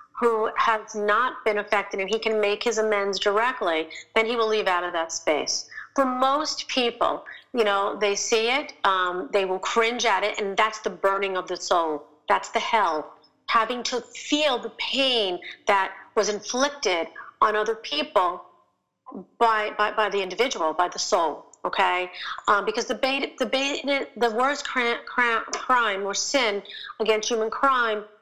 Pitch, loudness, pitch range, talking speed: 220 Hz, -24 LUFS, 200-245 Hz, 165 wpm